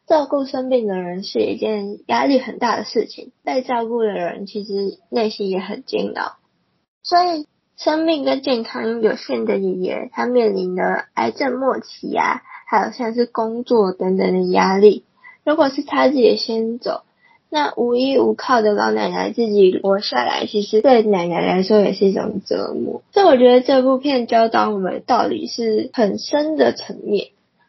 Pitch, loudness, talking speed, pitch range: 230 Hz, -18 LUFS, 255 characters per minute, 205-265 Hz